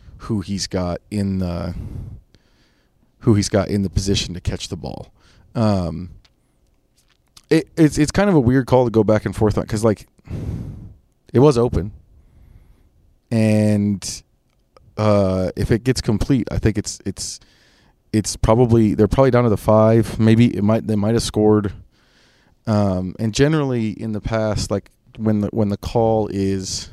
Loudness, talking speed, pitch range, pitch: -19 LUFS, 165 wpm, 95-115 Hz, 105 Hz